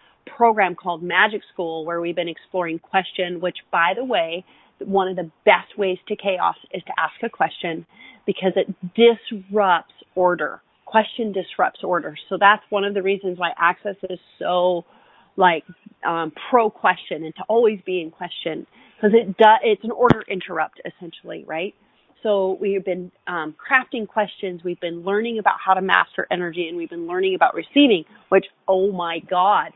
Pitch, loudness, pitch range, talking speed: 190 Hz, -21 LUFS, 175-215 Hz, 170 wpm